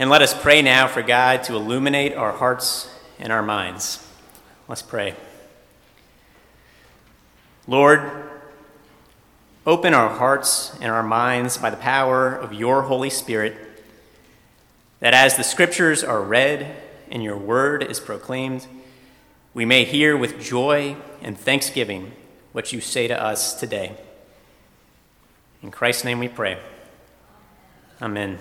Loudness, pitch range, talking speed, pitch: -19 LUFS, 115-140 Hz, 125 wpm, 130 Hz